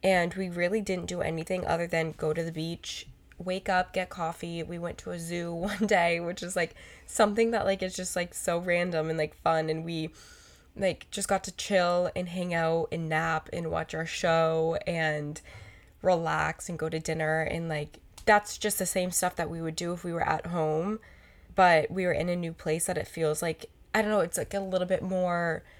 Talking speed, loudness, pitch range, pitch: 220 wpm, -29 LUFS, 160-185 Hz, 170 Hz